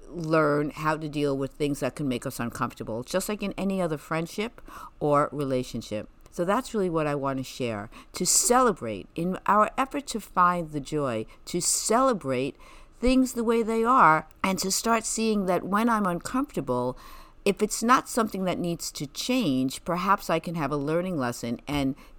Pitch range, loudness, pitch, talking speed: 145-215 Hz, -26 LUFS, 170 Hz, 180 wpm